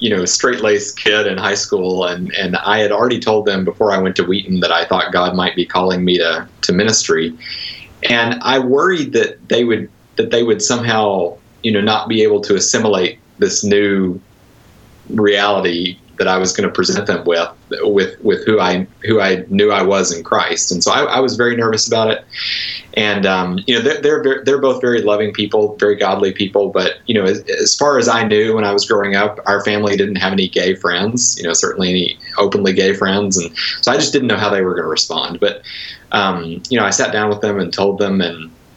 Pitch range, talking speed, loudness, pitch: 95-115 Hz, 225 wpm, -15 LUFS, 100 Hz